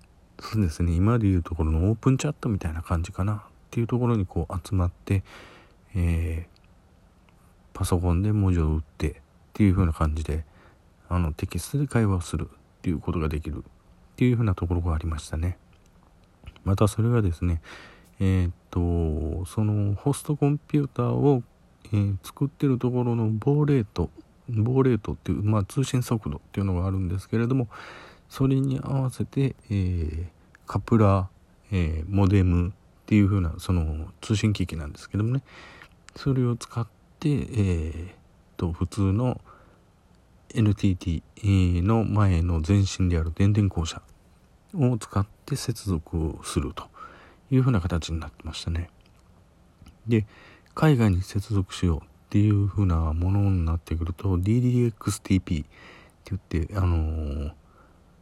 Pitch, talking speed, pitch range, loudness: 95 Hz, 305 characters per minute, 85-110 Hz, -26 LUFS